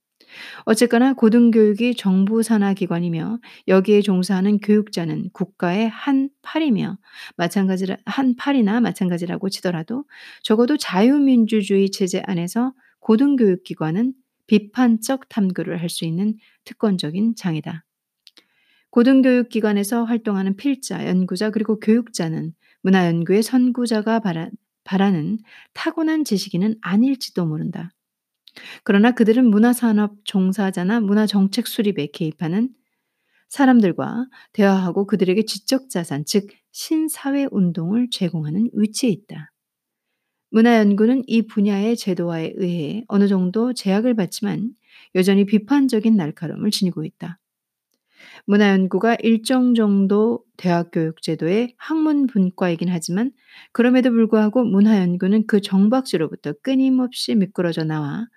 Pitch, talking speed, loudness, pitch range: 210 Hz, 305 characters per minute, -19 LUFS, 190-235 Hz